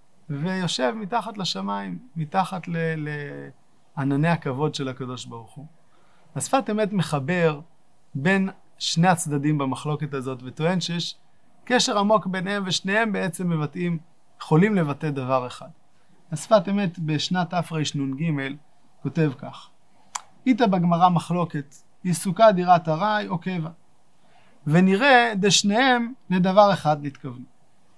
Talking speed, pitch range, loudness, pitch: 105 wpm, 145-190 Hz, -23 LUFS, 170 Hz